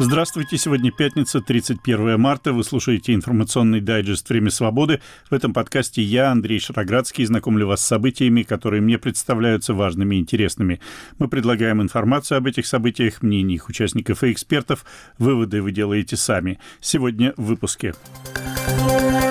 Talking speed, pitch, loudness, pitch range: 135 wpm, 115 Hz, -20 LUFS, 110-130 Hz